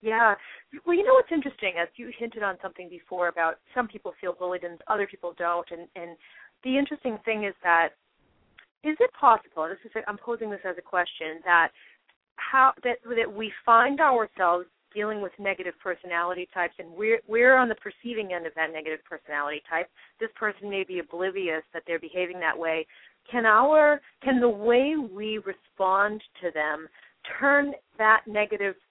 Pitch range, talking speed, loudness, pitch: 175-235 Hz, 180 wpm, -26 LUFS, 200 Hz